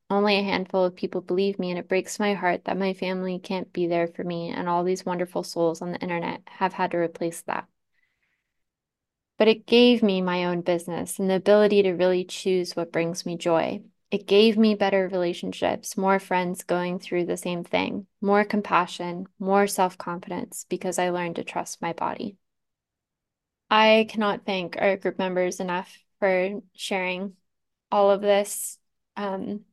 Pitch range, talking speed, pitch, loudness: 180-200 Hz, 175 wpm, 185 Hz, -25 LUFS